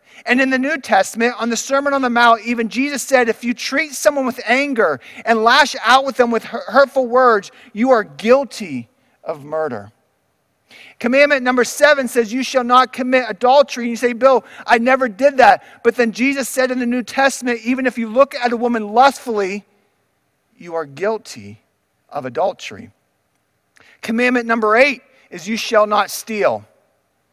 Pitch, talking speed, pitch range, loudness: 245 Hz, 175 wpm, 225-265 Hz, -16 LUFS